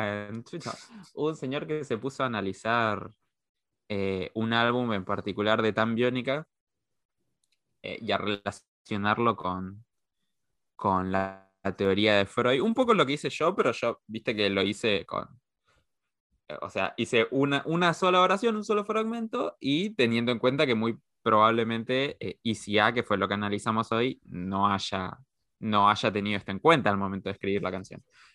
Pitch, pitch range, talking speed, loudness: 110 Hz, 100-135 Hz, 165 wpm, -27 LUFS